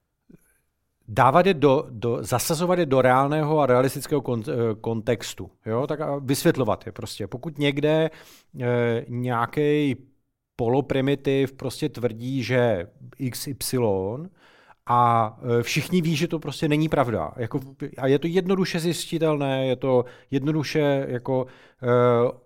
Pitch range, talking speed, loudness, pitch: 120-150 Hz, 125 wpm, -23 LUFS, 135 Hz